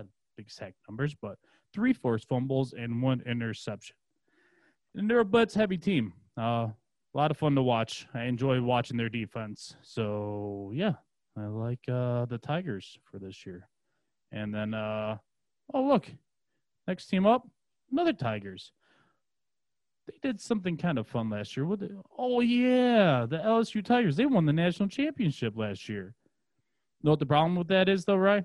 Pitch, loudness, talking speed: 135 Hz, -29 LUFS, 160 wpm